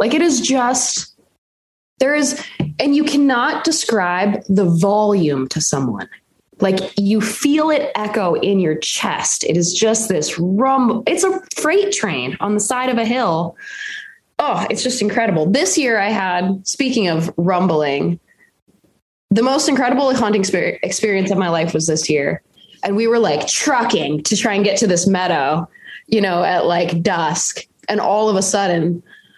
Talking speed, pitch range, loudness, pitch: 165 wpm, 180-255 Hz, -17 LUFS, 210 Hz